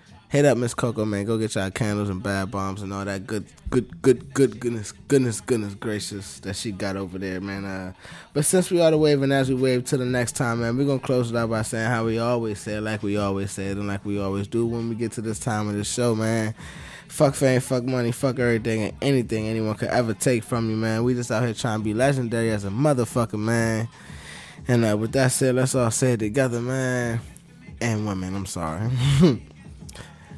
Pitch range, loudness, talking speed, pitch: 105-125 Hz, -24 LUFS, 240 wpm, 115 Hz